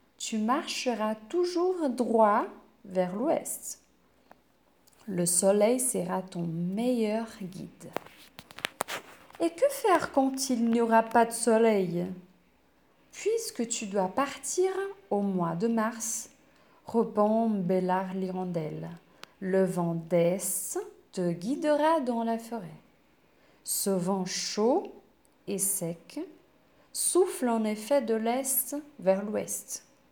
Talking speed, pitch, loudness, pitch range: 105 wpm, 225 Hz, -29 LUFS, 185-270 Hz